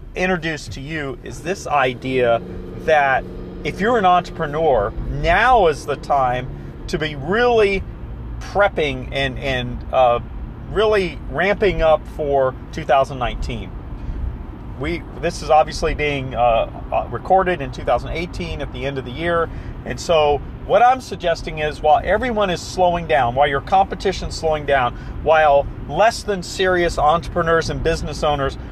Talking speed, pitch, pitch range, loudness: 140 wpm, 150 Hz, 130-175 Hz, -19 LUFS